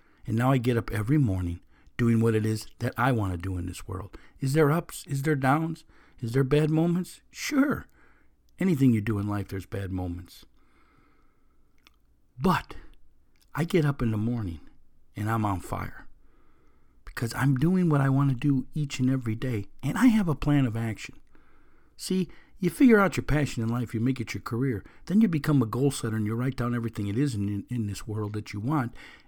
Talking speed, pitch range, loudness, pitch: 210 wpm, 105-145 Hz, -27 LUFS, 120 Hz